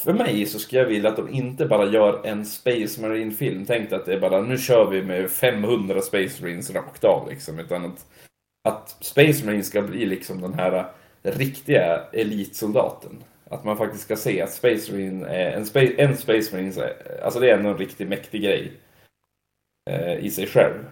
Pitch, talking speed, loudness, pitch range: 105 Hz, 185 wpm, -22 LUFS, 95-130 Hz